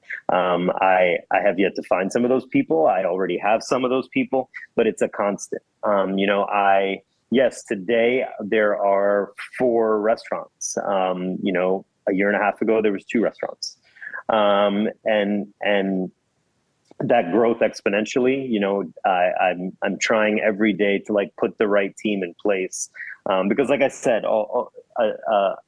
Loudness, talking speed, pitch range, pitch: -21 LUFS, 180 wpm, 95-115 Hz, 105 Hz